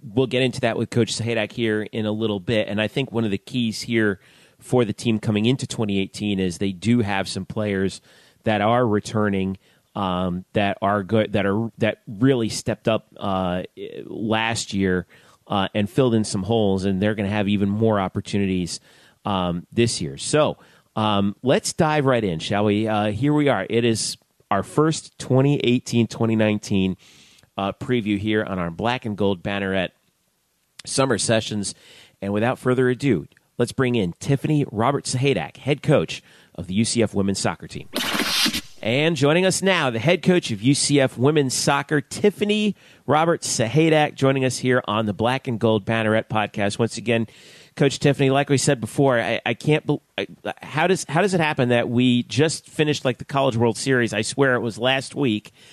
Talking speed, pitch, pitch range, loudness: 180 wpm, 115 Hz, 105-135 Hz, -22 LUFS